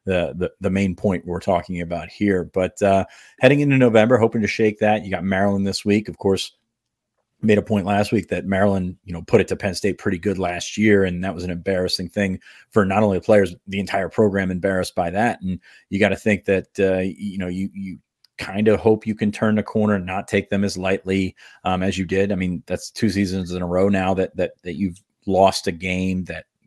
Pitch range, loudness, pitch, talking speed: 90-105 Hz, -21 LUFS, 95 Hz, 235 wpm